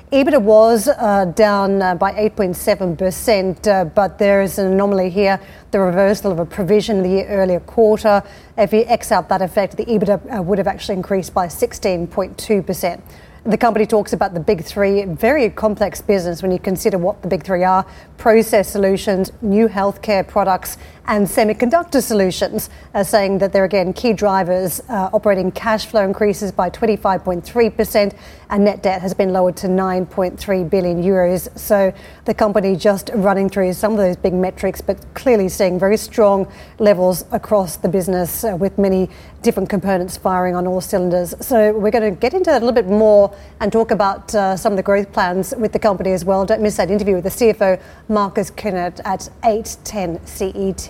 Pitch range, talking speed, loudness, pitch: 190-215 Hz, 180 wpm, -16 LUFS, 200 Hz